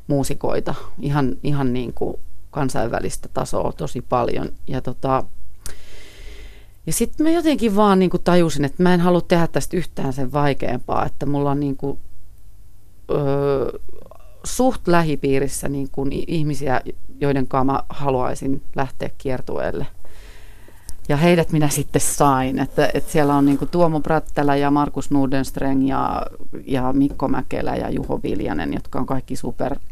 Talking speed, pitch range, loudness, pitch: 140 wpm, 130-150 Hz, -21 LUFS, 140 Hz